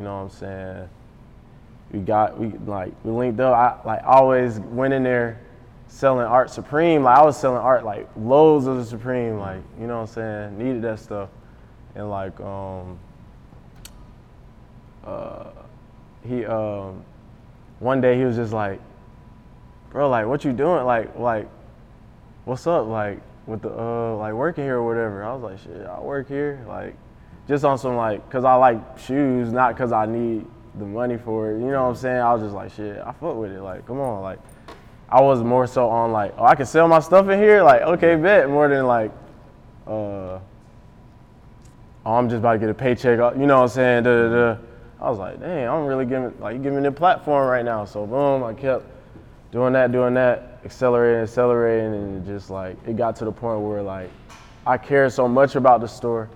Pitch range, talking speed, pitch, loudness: 110-130 Hz, 205 wpm, 120 Hz, -20 LUFS